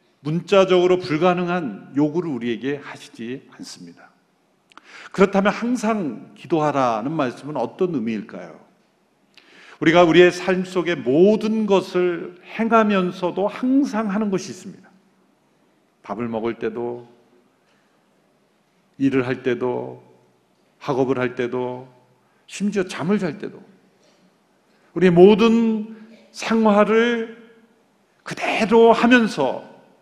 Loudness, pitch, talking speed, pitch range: -19 LUFS, 180 Hz, 220 characters per minute, 130-215 Hz